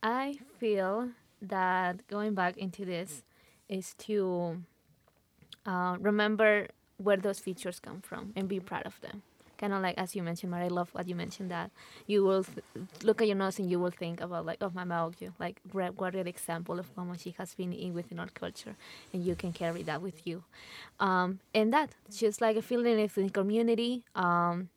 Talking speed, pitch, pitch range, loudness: 205 wpm, 190 Hz, 180-210 Hz, -33 LUFS